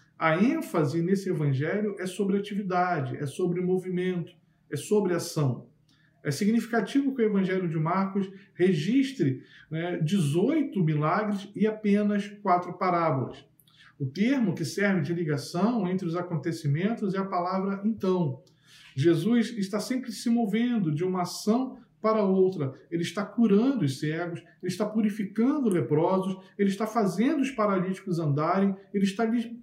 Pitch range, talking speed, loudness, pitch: 165-210 Hz, 135 wpm, -27 LUFS, 185 Hz